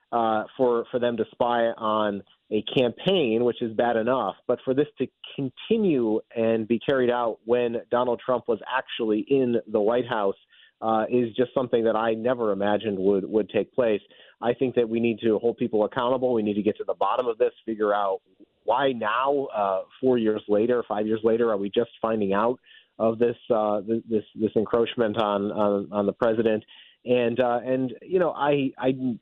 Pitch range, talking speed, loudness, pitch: 110-125 Hz, 195 wpm, -25 LUFS, 115 Hz